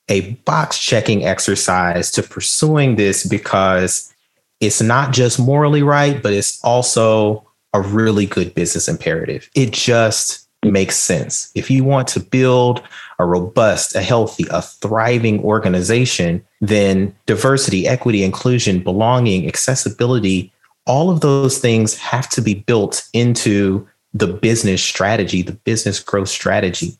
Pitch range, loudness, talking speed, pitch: 100-125 Hz, -15 LUFS, 130 wpm, 110 Hz